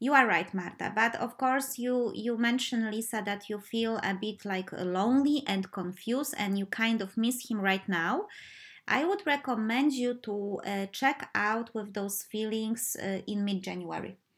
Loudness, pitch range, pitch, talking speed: -31 LUFS, 195-245 Hz, 220 Hz, 175 wpm